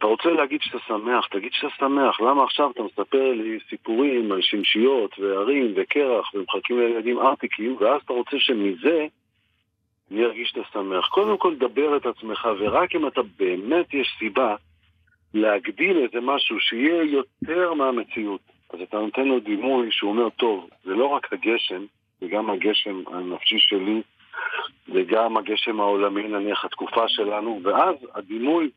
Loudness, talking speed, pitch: -23 LUFS, 145 wpm, 125 Hz